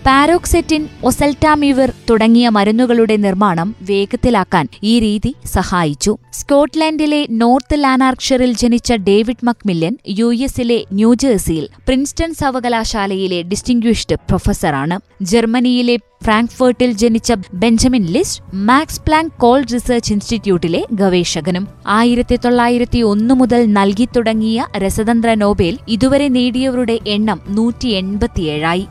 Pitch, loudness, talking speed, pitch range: 235 Hz, -14 LUFS, 95 wpm, 205-250 Hz